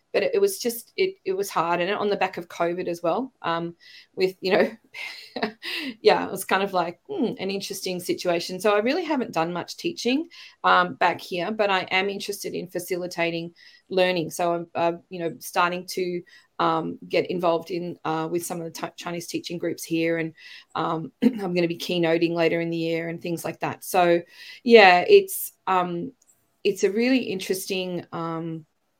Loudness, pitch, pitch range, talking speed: -24 LUFS, 180 Hz, 170-220 Hz, 190 wpm